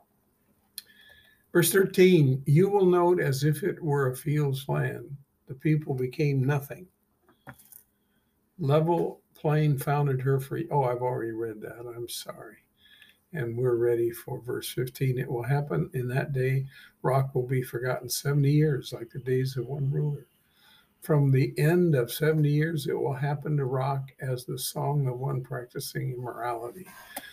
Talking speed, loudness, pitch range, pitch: 155 wpm, -27 LUFS, 130-155 Hz, 140 Hz